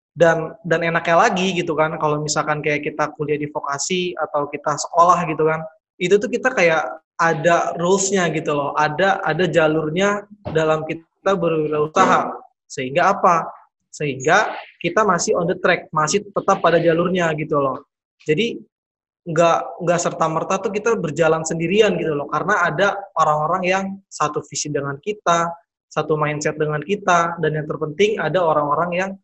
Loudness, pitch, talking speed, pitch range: -19 LUFS, 165 Hz, 155 wpm, 155-185 Hz